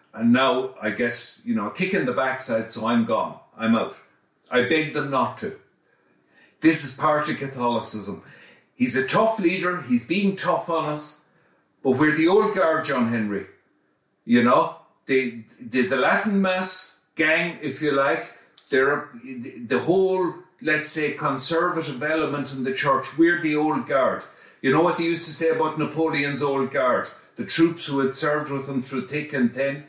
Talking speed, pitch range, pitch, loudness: 180 wpm, 130-165 Hz, 150 Hz, -23 LUFS